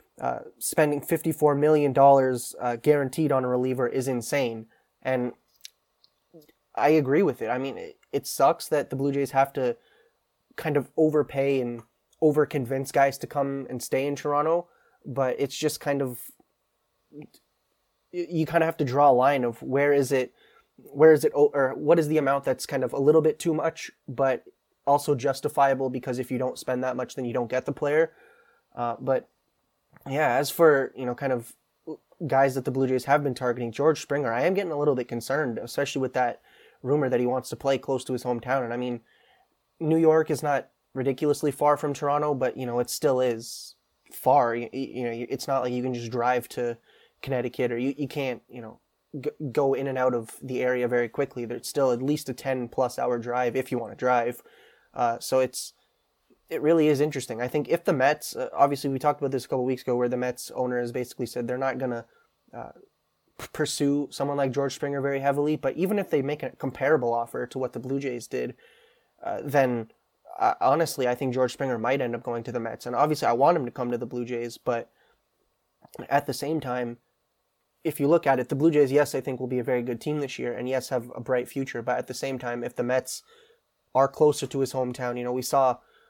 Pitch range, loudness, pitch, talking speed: 125-145 Hz, -26 LUFS, 135 Hz, 220 wpm